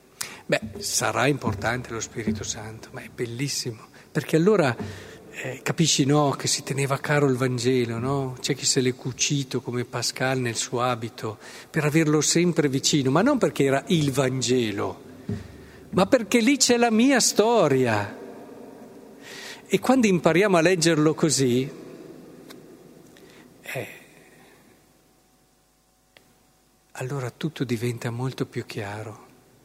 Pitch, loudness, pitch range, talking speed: 135 Hz, -23 LUFS, 125-160 Hz, 125 wpm